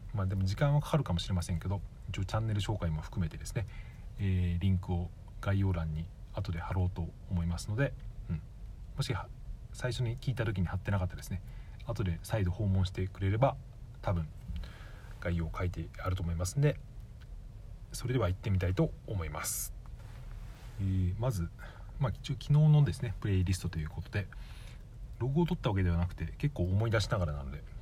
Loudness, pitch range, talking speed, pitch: -34 LUFS, 90-115 Hz, 380 characters per minute, 100 Hz